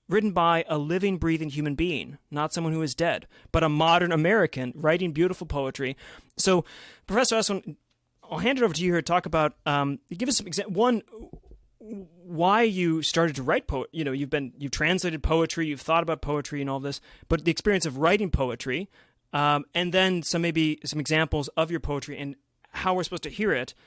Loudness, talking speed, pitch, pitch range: -26 LUFS, 205 wpm, 165 Hz, 150-180 Hz